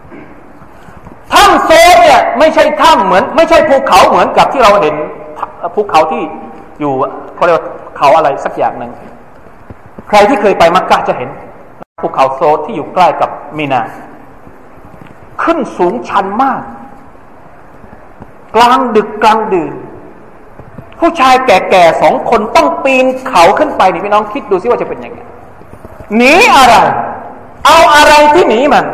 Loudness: -8 LUFS